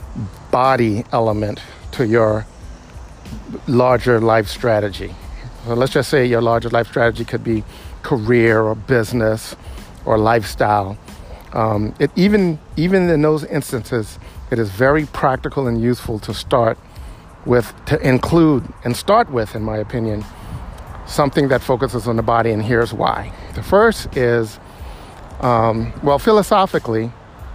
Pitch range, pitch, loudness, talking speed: 110-130 Hz, 115 Hz, -17 LUFS, 135 wpm